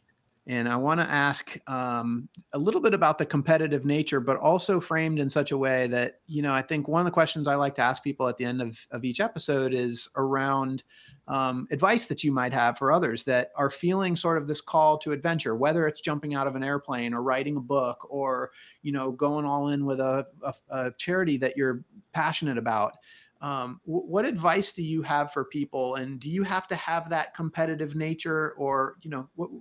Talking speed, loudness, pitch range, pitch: 215 wpm, -27 LUFS, 130-160 Hz, 145 Hz